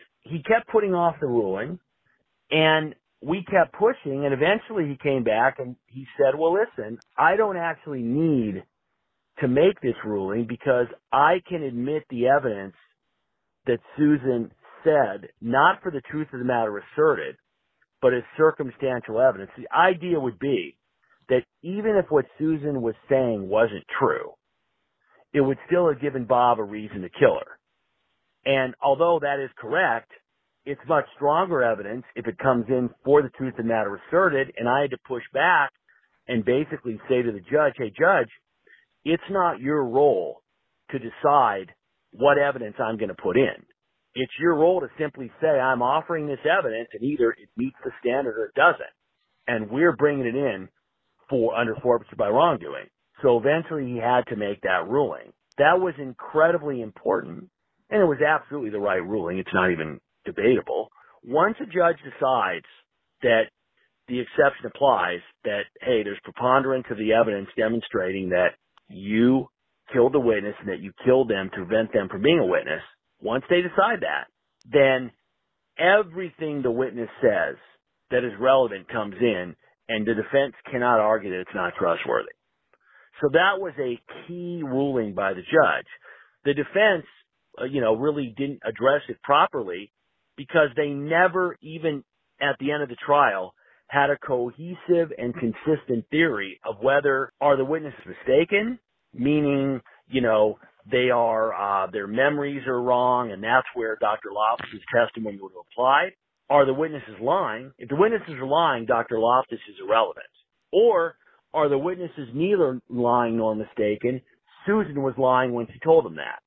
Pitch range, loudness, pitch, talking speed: 120-155 Hz, -23 LUFS, 135 Hz, 160 wpm